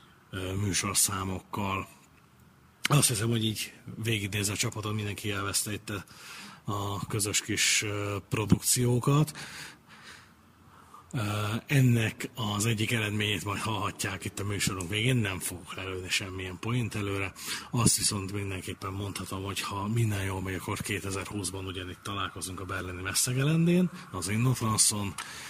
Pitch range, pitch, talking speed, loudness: 95-110 Hz, 100 Hz, 115 wpm, -29 LUFS